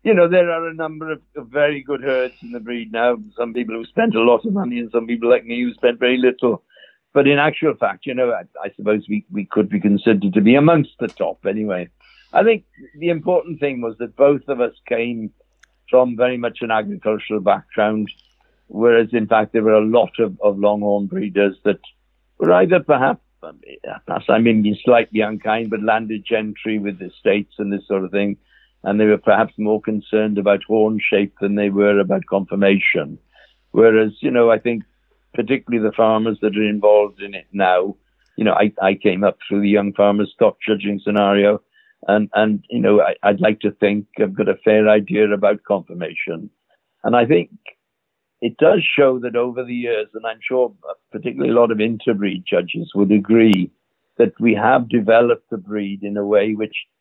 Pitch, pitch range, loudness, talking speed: 110 Hz, 105-120 Hz, -18 LUFS, 195 wpm